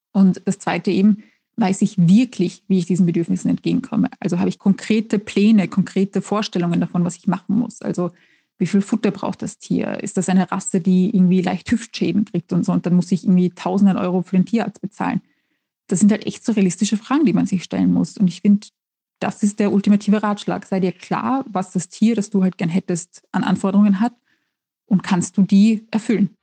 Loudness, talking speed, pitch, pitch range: -19 LUFS, 210 wpm, 195 Hz, 185-210 Hz